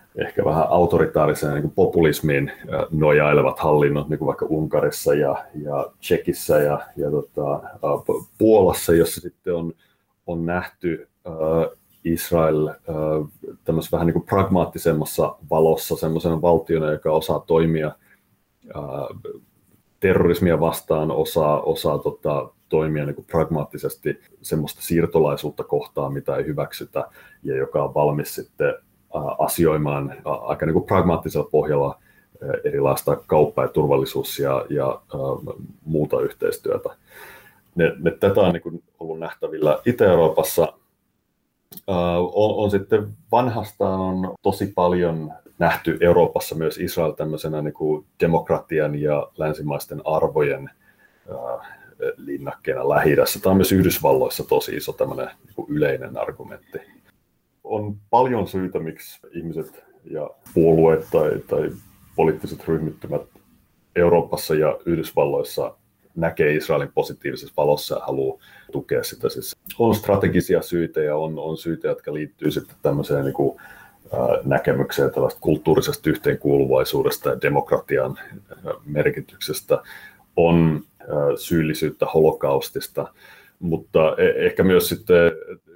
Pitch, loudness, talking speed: 95 Hz, -21 LUFS, 115 wpm